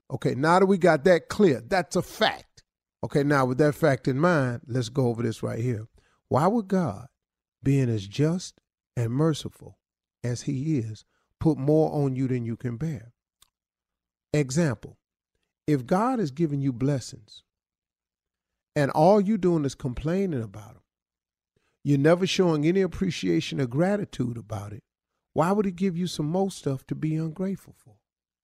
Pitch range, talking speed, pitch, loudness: 120-170 Hz, 165 wpm, 145 Hz, -25 LUFS